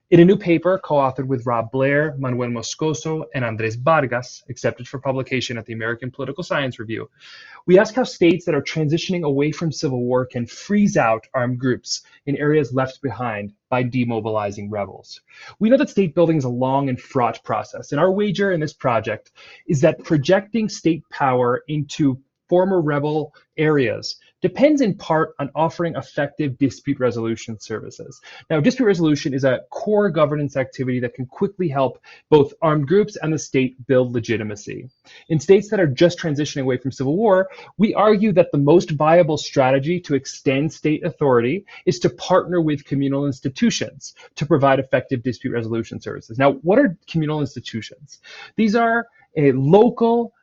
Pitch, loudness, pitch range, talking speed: 145 Hz, -20 LUFS, 130-175 Hz, 170 wpm